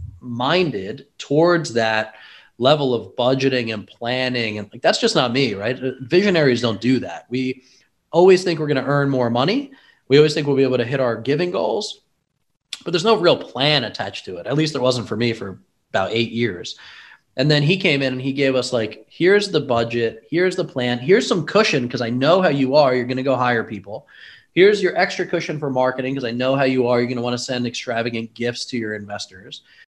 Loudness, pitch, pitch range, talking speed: -19 LUFS, 130 Hz, 120-155 Hz, 225 wpm